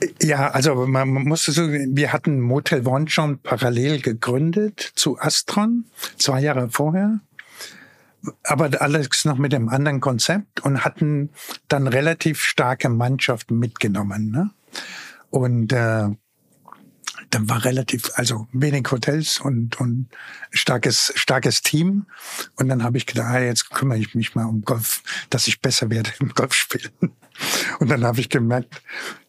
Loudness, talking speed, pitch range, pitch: -20 LUFS, 140 wpm, 120-150 Hz, 135 Hz